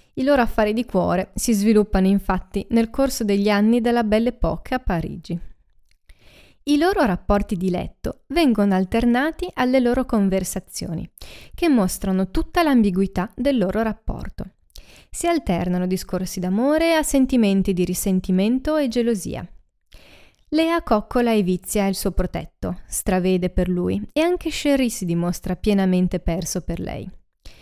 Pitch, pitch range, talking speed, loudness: 205 Hz, 185-255 Hz, 135 wpm, -21 LUFS